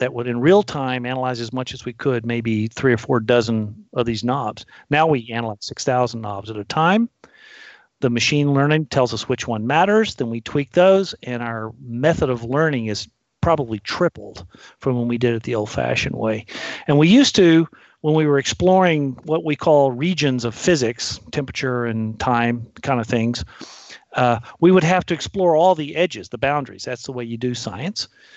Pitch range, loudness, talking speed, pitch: 115-155 Hz, -20 LUFS, 195 wpm, 130 Hz